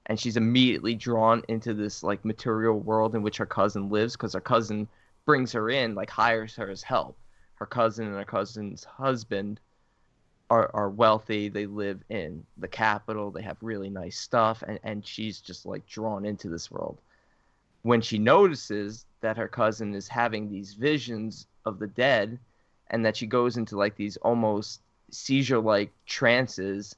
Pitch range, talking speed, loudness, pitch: 105-115 Hz, 170 wpm, -27 LUFS, 110 Hz